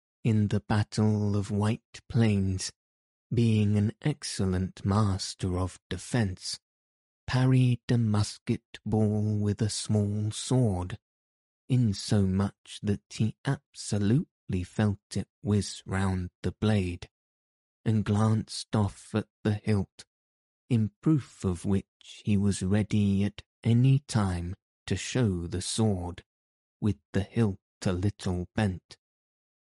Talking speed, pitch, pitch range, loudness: 115 wpm, 105 Hz, 95-110 Hz, -29 LUFS